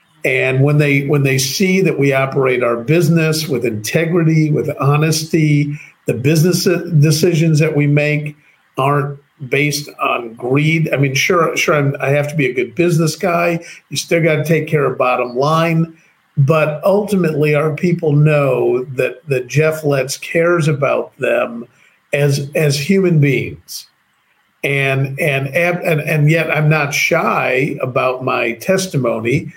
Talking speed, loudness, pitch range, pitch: 150 wpm, -15 LUFS, 135-165 Hz, 150 Hz